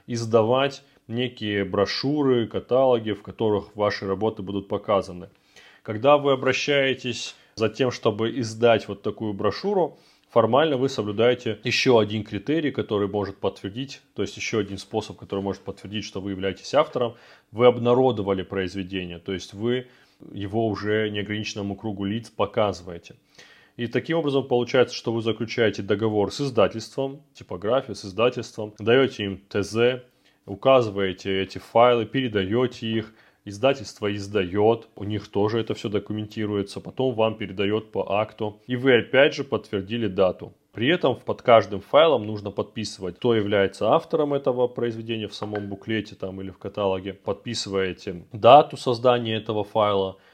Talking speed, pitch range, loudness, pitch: 140 wpm, 100-120 Hz, -24 LUFS, 110 Hz